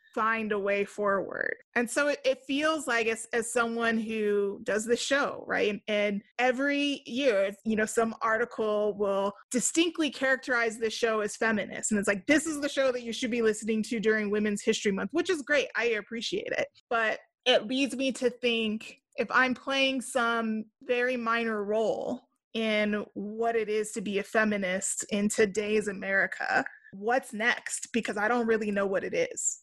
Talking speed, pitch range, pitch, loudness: 180 wpm, 210-255 Hz, 230 Hz, -28 LUFS